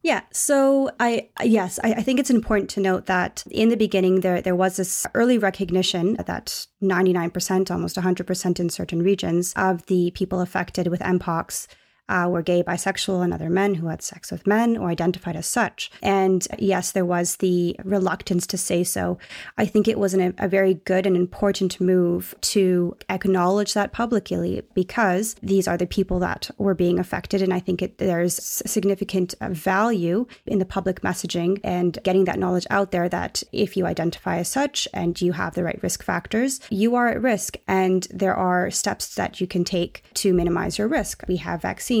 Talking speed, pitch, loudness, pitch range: 190 wpm, 185 Hz, -22 LUFS, 180-200 Hz